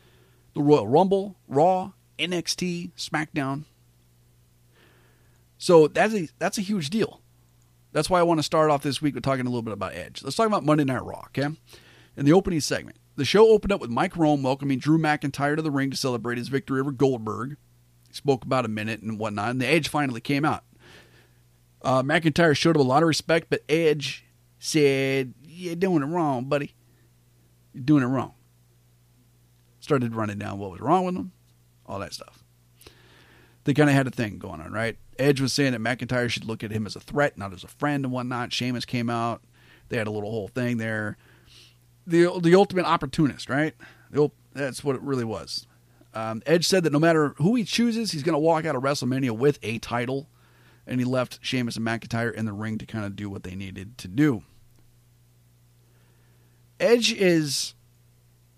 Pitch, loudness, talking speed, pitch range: 125 Hz, -24 LUFS, 195 wpm, 110-150 Hz